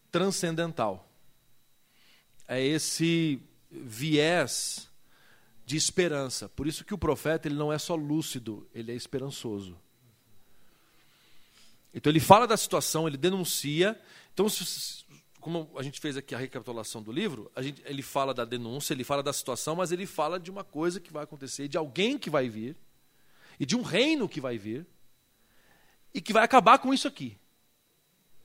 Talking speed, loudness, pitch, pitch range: 160 wpm, -29 LUFS, 150 Hz, 125-175 Hz